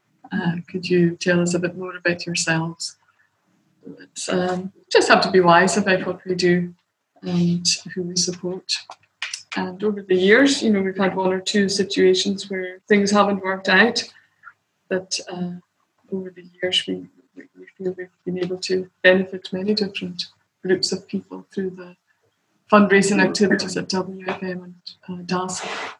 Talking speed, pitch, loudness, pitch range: 155 wpm, 185 Hz, -20 LUFS, 180-195 Hz